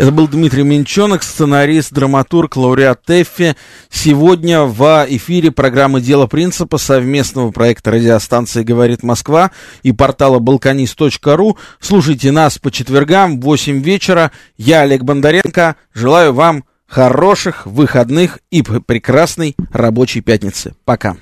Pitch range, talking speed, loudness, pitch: 130-160 Hz, 115 wpm, -11 LUFS, 140 Hz